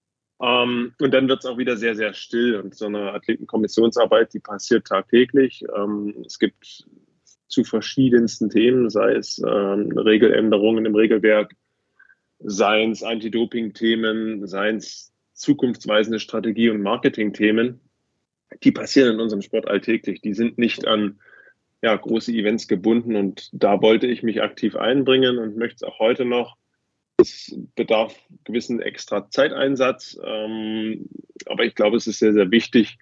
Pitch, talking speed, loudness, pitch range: 115 Hz, 140 wpm, -20 LUFS, 105-120 Hz